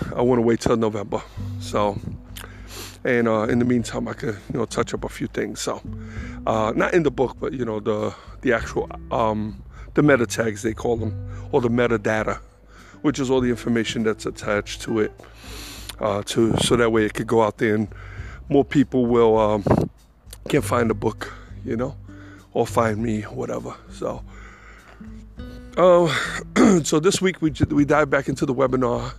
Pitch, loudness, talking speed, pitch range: 110 Hz, -22 LUFS, 185 wpm, 105-125 Hz